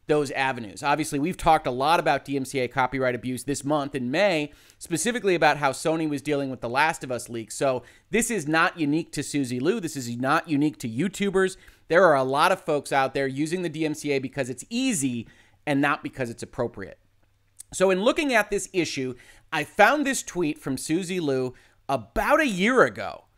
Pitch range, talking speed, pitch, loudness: 130-165 Hz, 200 wpm, 145 Hz, -25 LUFS